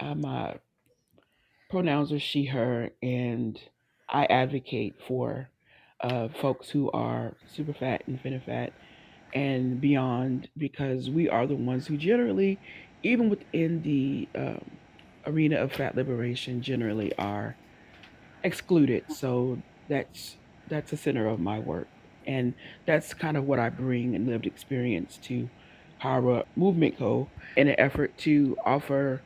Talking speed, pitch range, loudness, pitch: 130 wpm, 125-150 Hz, -29 LUFS, 130 Hz